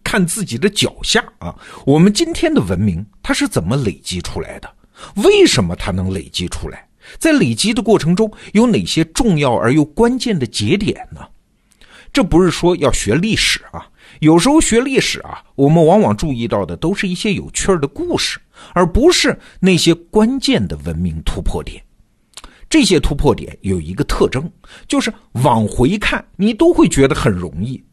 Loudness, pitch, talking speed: -15 LUFS, 175 Hz, 260 characters per minute